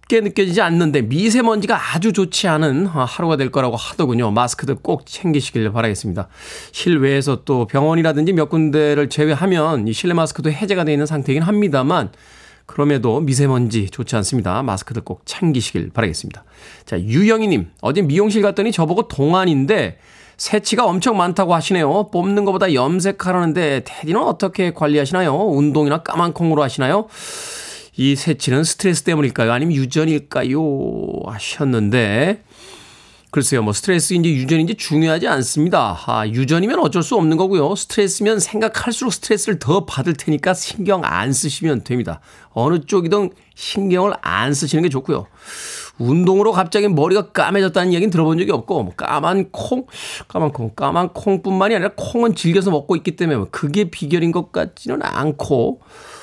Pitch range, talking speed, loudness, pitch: 140-195 Hz, 375 characters per minute, -17 LUFS, 160 Hz